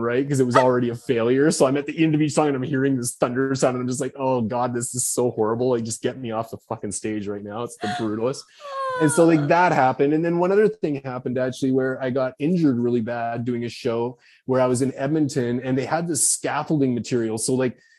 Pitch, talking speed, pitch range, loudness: 130 Hz, 260 wpm, 120-145 Hz, -22 LUFS